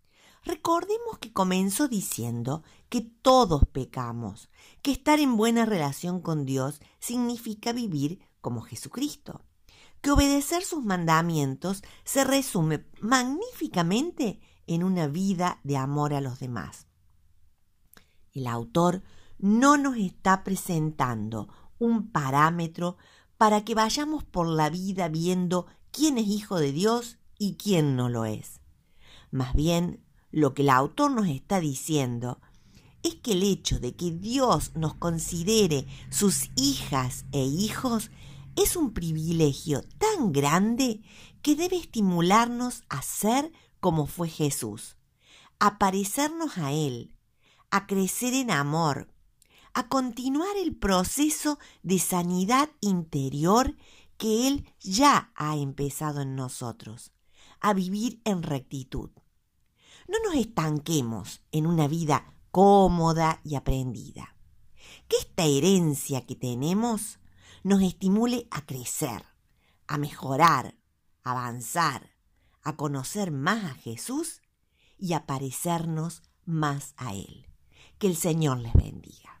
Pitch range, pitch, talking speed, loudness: 140-220 Hz, 170 Hz, 120 wpm, -27 LUFS